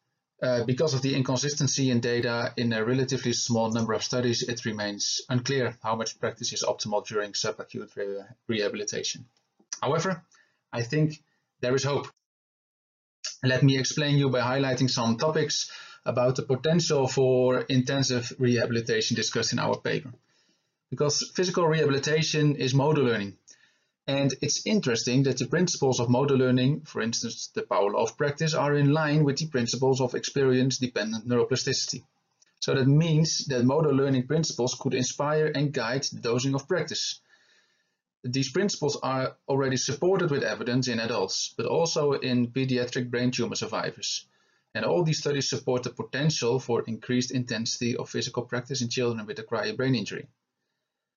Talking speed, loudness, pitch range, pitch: 155 wpm, -26 LUFS, 120-145 Hz, 130 Hz